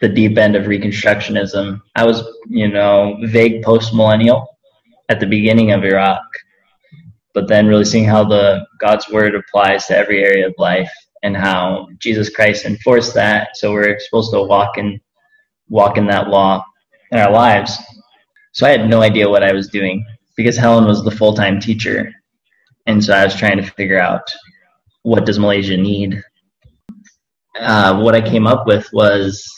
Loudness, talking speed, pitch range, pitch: -13 LUFS, 170 wpm, 100-115 Hz, 105 Hz